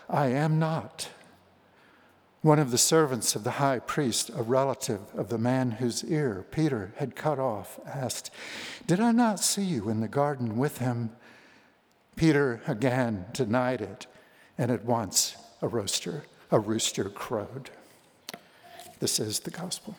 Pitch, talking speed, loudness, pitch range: 130 Hz, 145 wpm, -28 LUFS, 120-155 Hz